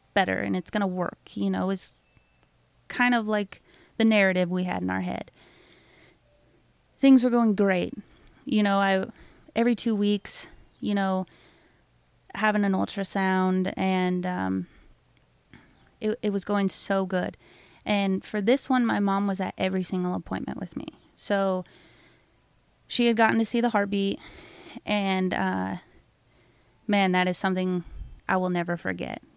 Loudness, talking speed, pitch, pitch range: -26 LUFS, 150 wpm, 195 Hz, 180-210 Hz